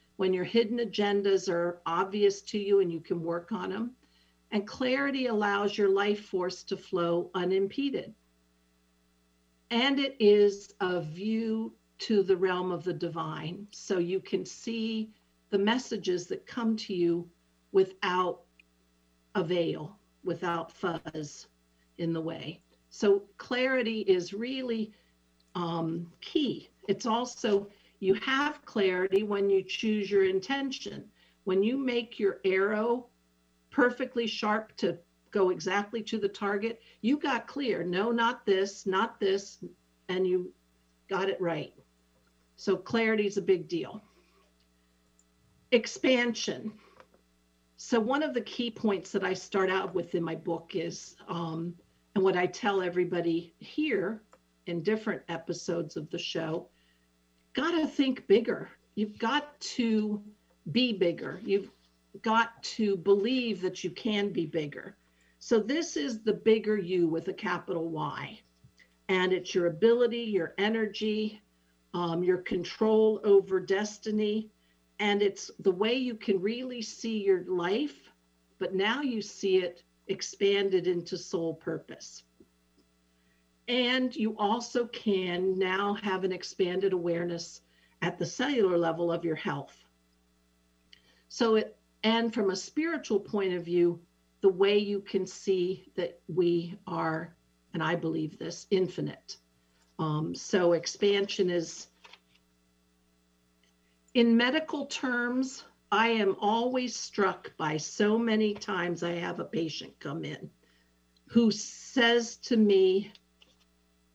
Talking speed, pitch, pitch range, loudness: 130 wpm, 190 Hz, 165-215 Hz, -30 LUFS